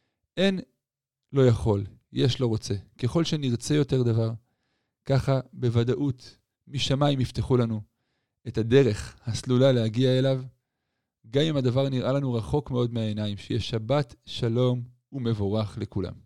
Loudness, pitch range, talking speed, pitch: -26 LUFS, 115-135 Hz, 120 wpm, 125 Hz